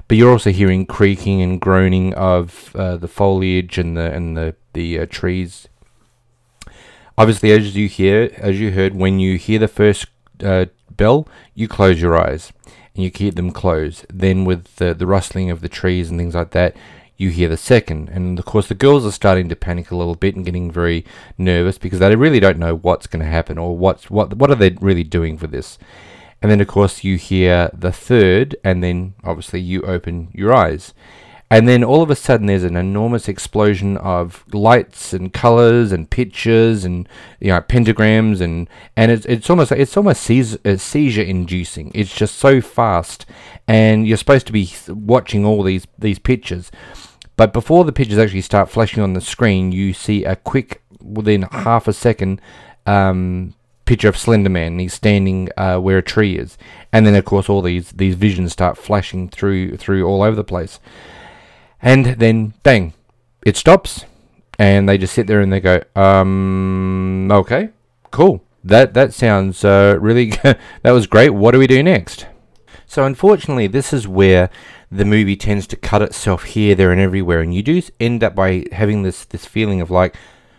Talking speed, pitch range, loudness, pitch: 190 wpm, 90-110 Hz, -15 LUFS, 100 Hz